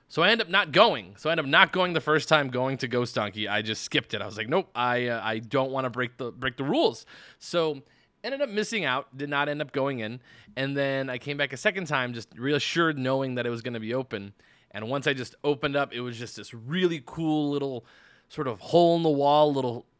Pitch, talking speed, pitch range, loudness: 135 Hz, 260 wpm, 120-150 Hz, -26 LUFS